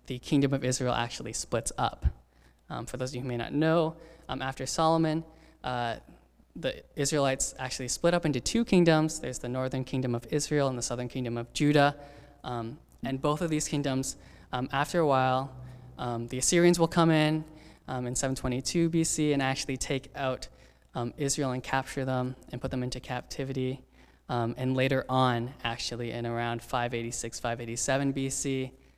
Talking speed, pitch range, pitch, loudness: 175 wpm, 120-145 Hz, 130 Hz, -30 LUFS